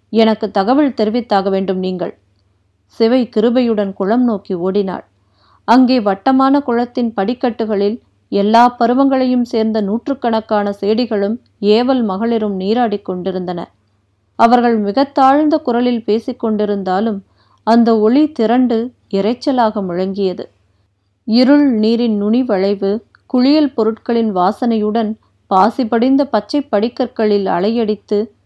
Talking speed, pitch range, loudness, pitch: 90 wpm, 200-245 Hz, -15 LUFS, 220 Hz